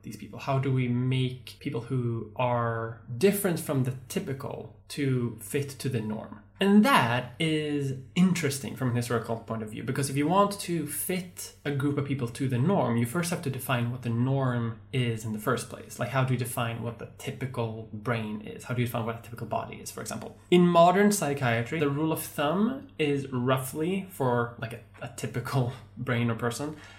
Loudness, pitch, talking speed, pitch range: -28 LUFS, 125 Hz, 205 wpm, 115-145 Hz